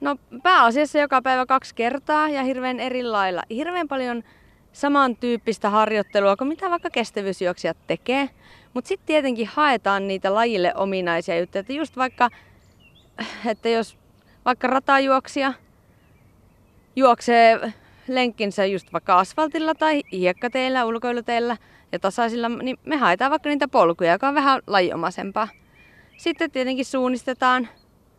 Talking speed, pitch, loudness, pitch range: 120 wpm, 245 Hz, -21 LUFS, 210-275 Hz